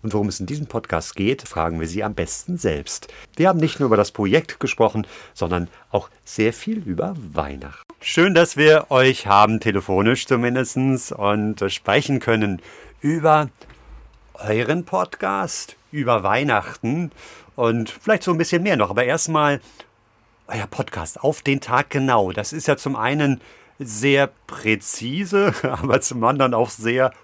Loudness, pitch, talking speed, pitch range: -20 LUFS, 120 Hz, 150 wpm, 105-145 Hz